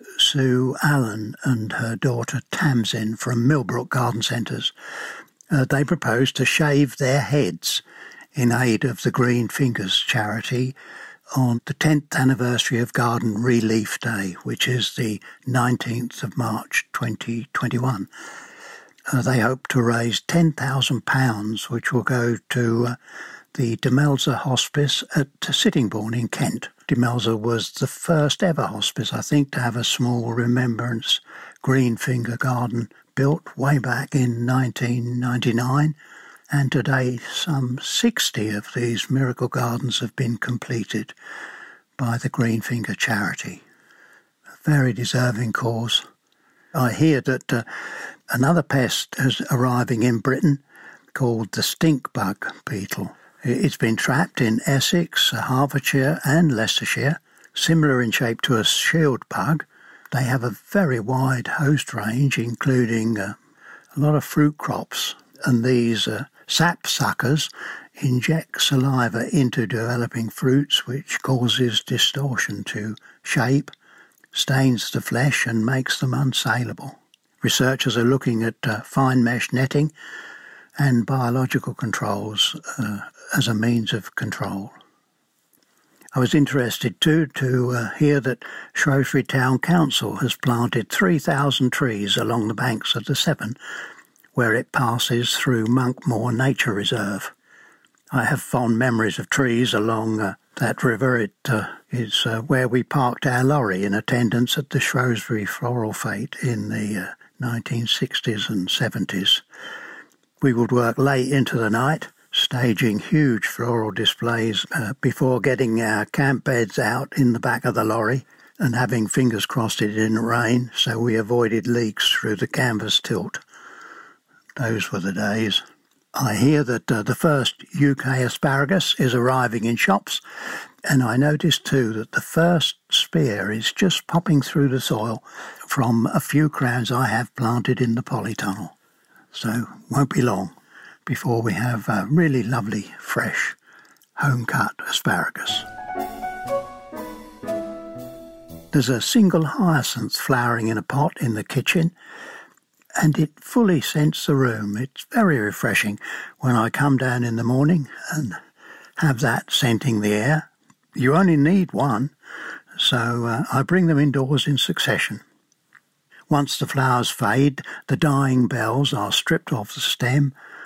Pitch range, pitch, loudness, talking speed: 115-140 Hz, 125 Hz, -21 LUFS, 135 wpm